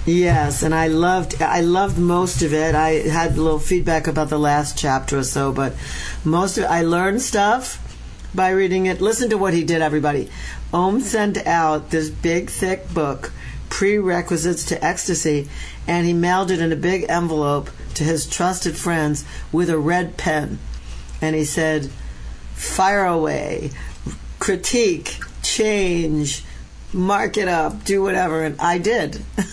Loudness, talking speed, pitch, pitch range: -20 LUFS, 155 wpm, 165 Hz, 150-185 Hz